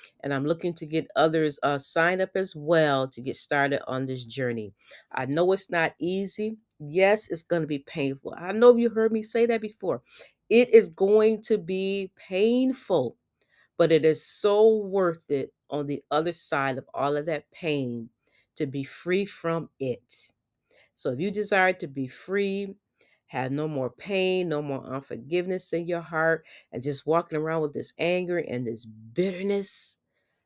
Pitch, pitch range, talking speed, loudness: 165 Hz, 140-195 Hz, 175 wpm, -26 LUFS